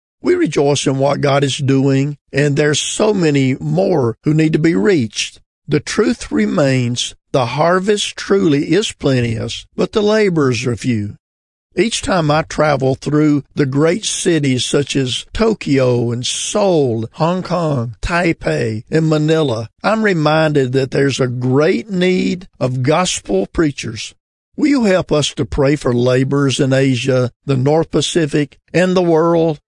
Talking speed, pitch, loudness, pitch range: 150 wpm, 145 Hz, -15 LUFS, 130-165 Hz